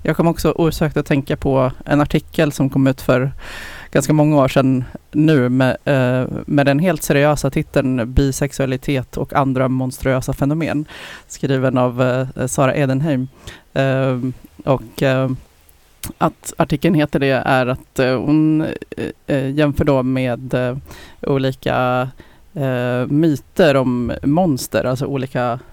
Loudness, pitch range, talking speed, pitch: -17 LUFS, 130-150 Hz, 115 wpm, 135 Hz